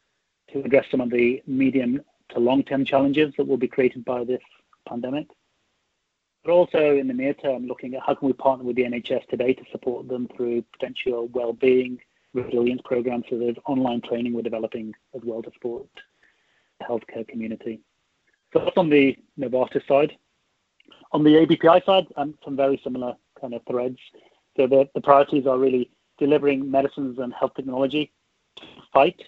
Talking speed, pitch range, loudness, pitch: 170 wpm, 125-140 Hz, -23 LUFS, 130 Hz